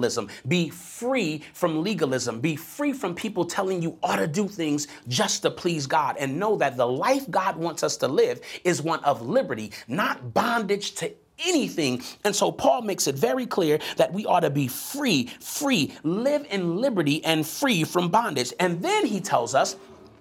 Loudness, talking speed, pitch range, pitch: -25 LUFS, 185 wpm, 155-235 Hz, 175 Hz